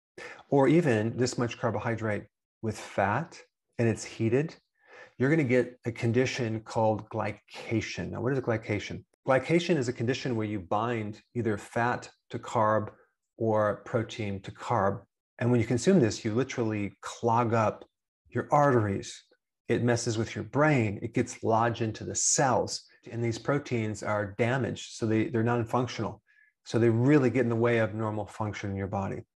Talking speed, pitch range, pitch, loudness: 170 wpm, 110-125 Hz, 115 Hz, -29 LUFS